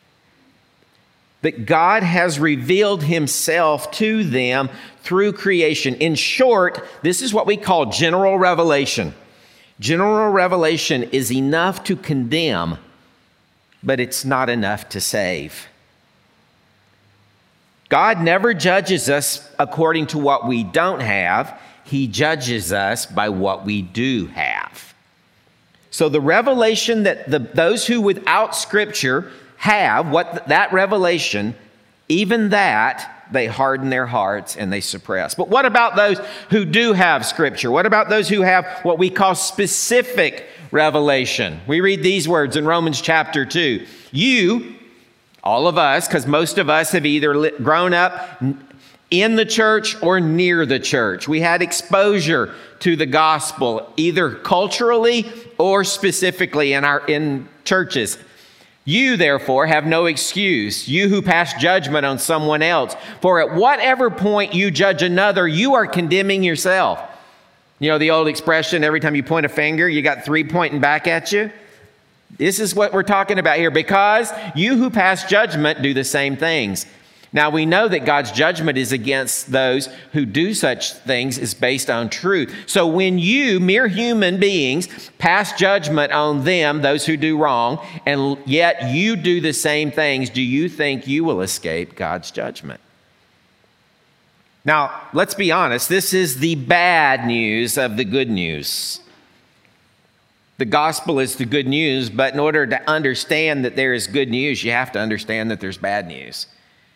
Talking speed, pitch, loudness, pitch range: 150 wpm, 160 Hz, -17 LUFS, 135-190 Hz